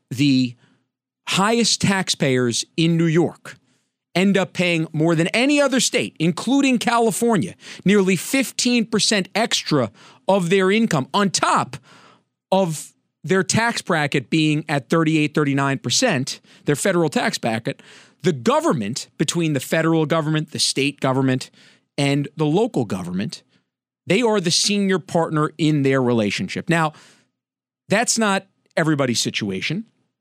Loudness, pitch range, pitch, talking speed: -19 LUFS, 145-200 Hz, 165 Hz, 125 wpm